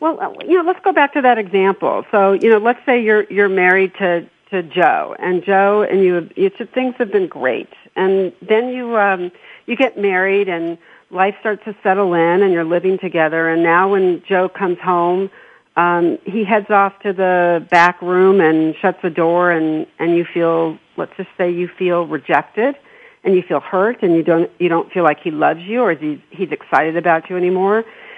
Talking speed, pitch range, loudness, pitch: 205 wpm, 175-210 Hz, -16 LUFS, 190 Hz